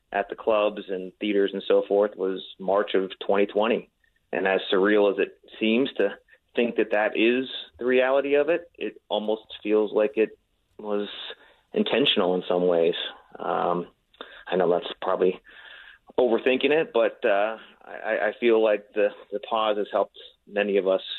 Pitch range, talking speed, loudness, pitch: 100-125 Hz, 165 wpm, -25 LUFS, 105 Hz